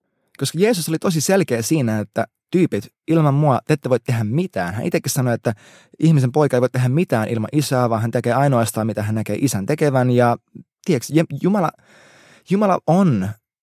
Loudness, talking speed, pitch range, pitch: -19 LUFS, 180 wpm, 120-160 Hz, 135 Hz